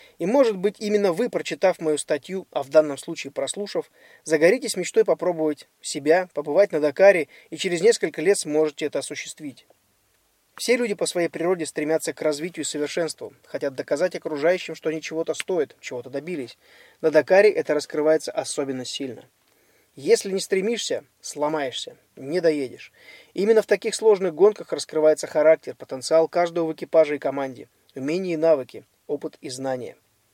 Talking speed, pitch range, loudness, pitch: 150 wpm, 150-200 Hz, -23 LUFS, 165 Hz